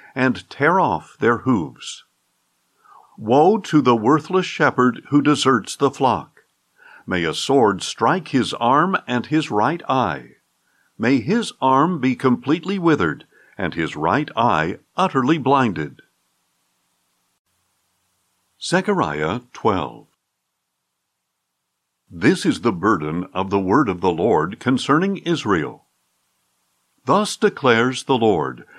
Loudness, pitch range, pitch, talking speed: -19 LUFS, 100-160 Hz, 130 Hz, 115 wpm